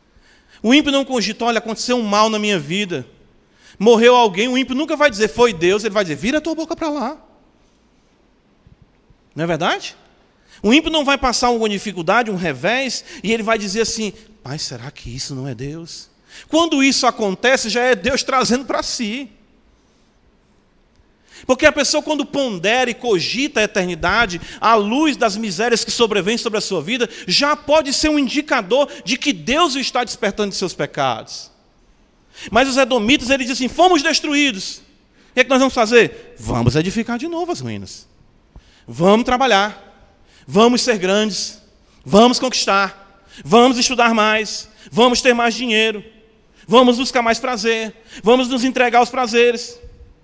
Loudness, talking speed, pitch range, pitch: -16 LUFS, 165 wpm, 205-260 Hz, 235 Hz